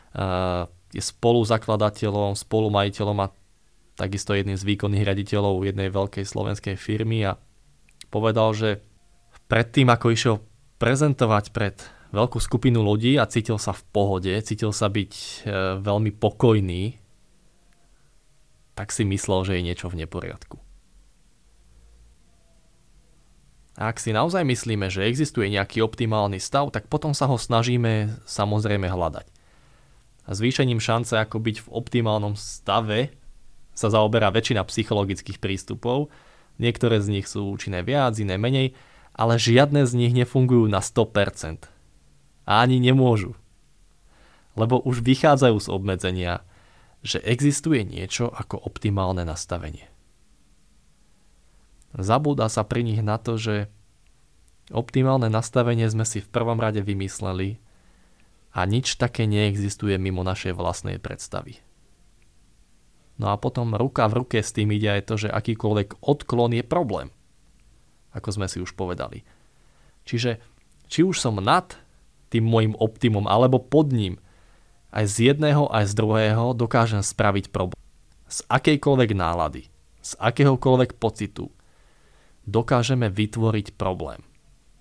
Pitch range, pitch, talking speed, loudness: 95-120 Hz, 110 Hz, 125 wpm, -23 LUFS